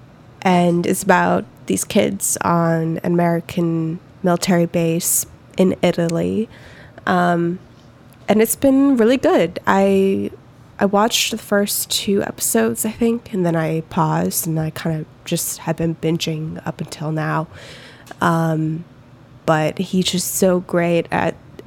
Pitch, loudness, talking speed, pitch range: 170 Hz, -18 LUFS, 135 wpm, 160-190 Hz